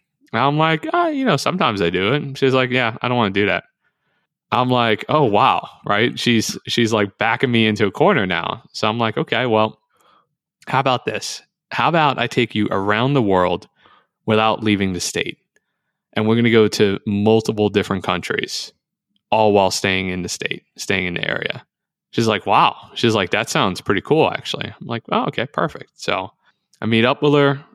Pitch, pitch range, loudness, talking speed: 110 Hz, 105-130 Hz, -18 LUFS, 200 wpm